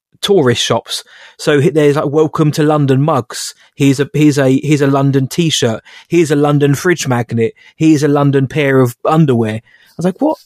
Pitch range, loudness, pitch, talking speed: 135-155 Hz, -13 LUFS, 145 Hz, 185 wpm